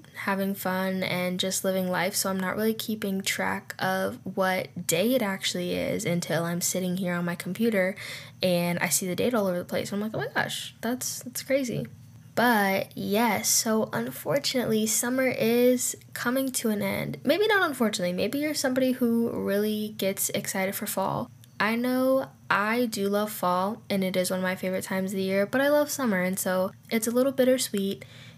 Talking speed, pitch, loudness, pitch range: 195 wpm, 195 Hz, -27 LUFS, 185-235 Hz